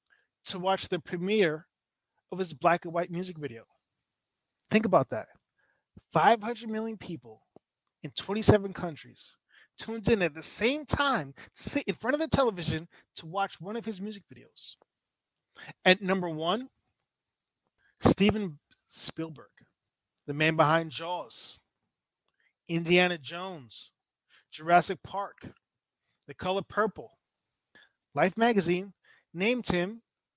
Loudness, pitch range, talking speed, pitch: -29 LUFS, 160-210 Hz, 120 wpm, 180 Hz